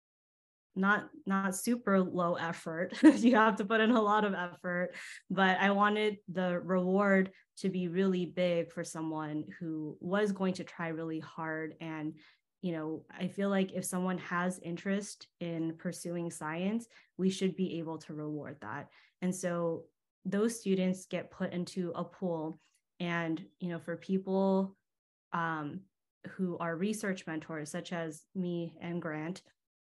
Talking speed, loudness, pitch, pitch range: 150 wpm, -34 LUFS, 180 Hz, 165-190 Hz